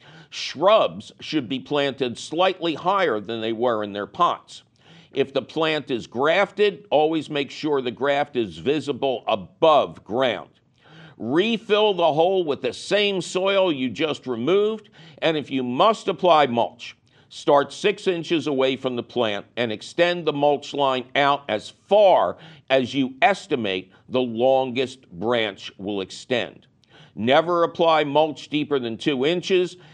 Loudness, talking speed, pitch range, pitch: -22 LUFS, 145 wpm, 125-175 Hz, 145 Hz